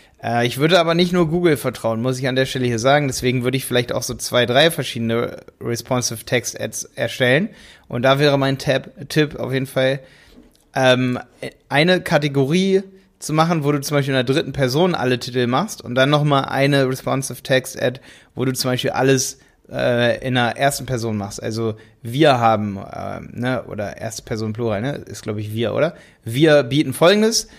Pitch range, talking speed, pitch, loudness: 120-145 Hz, 180 wpm, 130 Hz, -19 LUFS